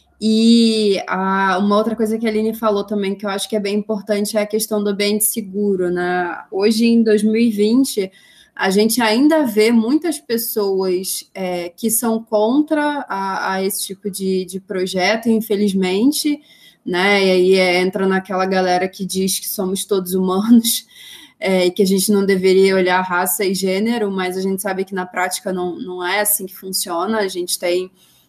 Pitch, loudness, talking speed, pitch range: 200 Hz, -17 LUFS, 180 wpm, 190-220 Hz